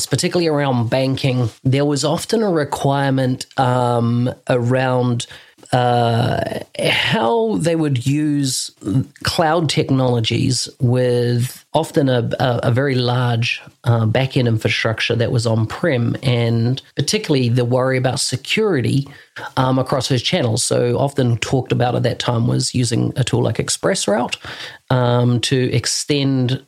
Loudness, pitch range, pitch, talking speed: -18 LUFS, 120-140 Hz, 130 Hz, 130 wpm